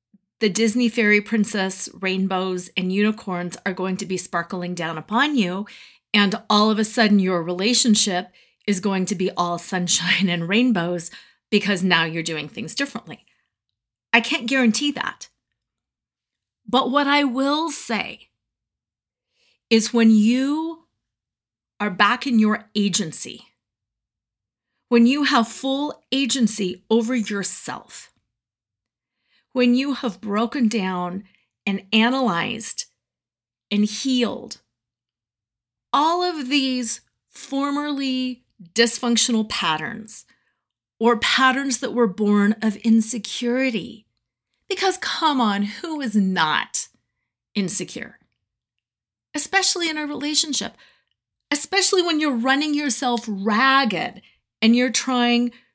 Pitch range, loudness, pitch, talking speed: 200-260 Hz, -20 LUFS, 225 Hz, 110 wpm